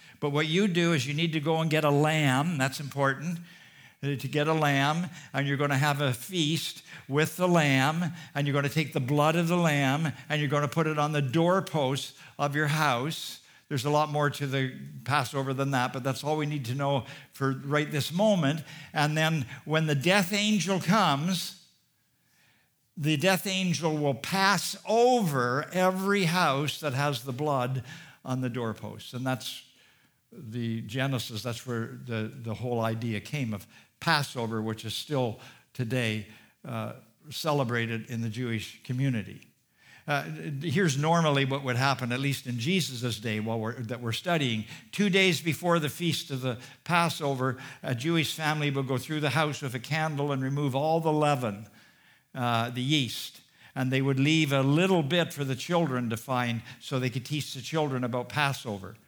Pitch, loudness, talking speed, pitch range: 140 Hz, -28 LUFS, 180 wpm, 125-160 Hz